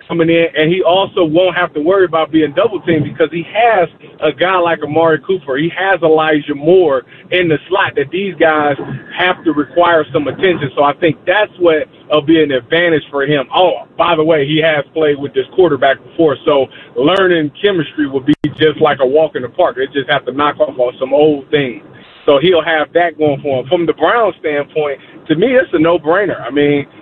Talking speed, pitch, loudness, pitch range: 220 wpm, 155 Hz, -13 LUFS, 145-175 Hz